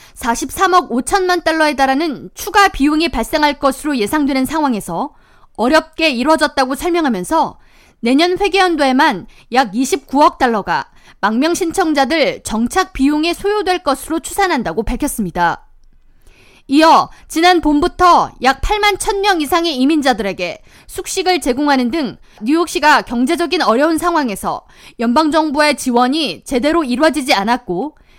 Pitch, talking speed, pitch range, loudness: 300 Hz, 305 characters per minute, 260-340 Hz, -14 LUFS